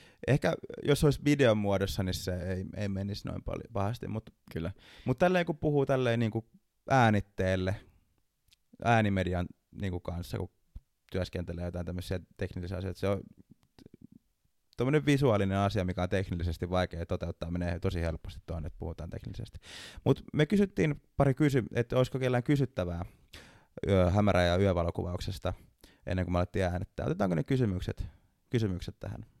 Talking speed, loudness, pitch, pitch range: 145 wpm, -31 LUFS, 95 Hz, 90-115 Hz